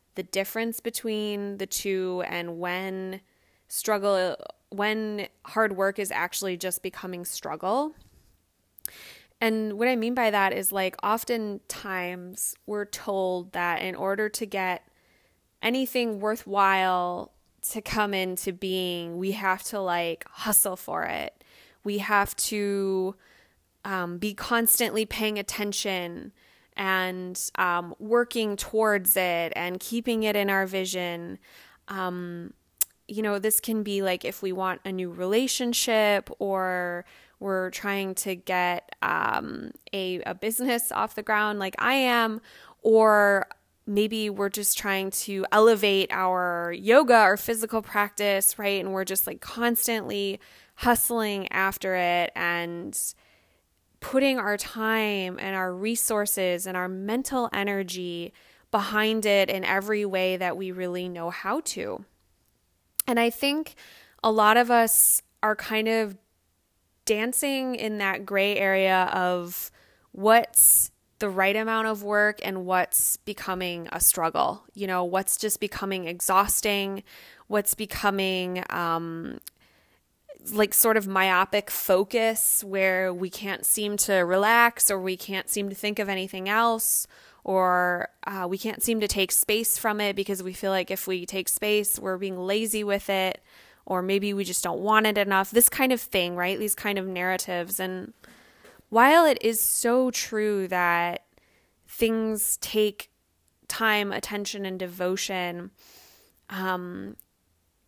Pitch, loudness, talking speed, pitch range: 195 Hz, -25 LUFS, 135 wpm, 185-220 Hz